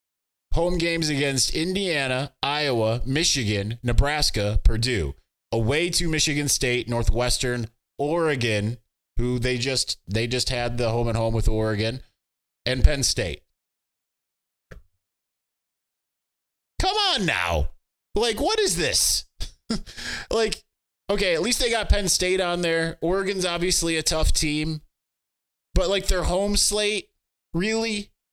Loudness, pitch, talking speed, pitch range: -23 LUFS, 135 Hz, 120 wpm, 110-175 Hz